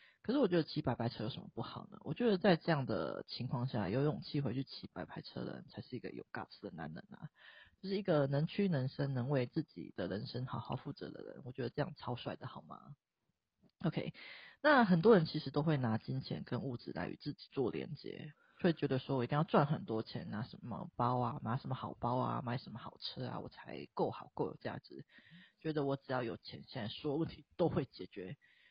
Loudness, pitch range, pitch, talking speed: -38 LUFS, 125-170 Hz, 145 Hz, 330 characters per minute